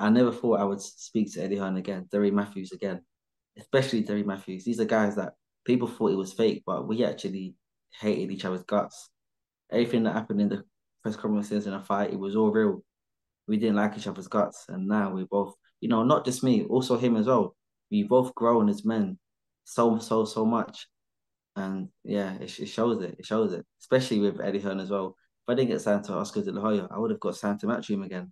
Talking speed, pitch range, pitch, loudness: 225 wpm, 100-115 Hz, 105 Hz, -28 LUFS